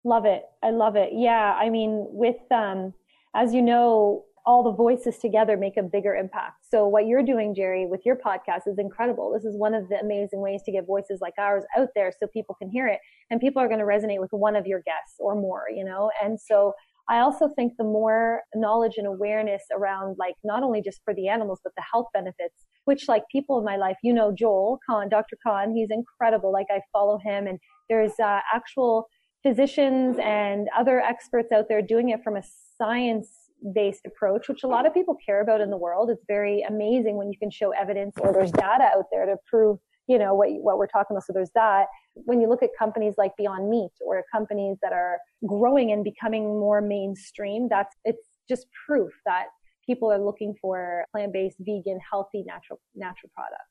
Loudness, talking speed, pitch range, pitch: -24 LUFS, 210 wpm, 200-230 Hz, 210 Hz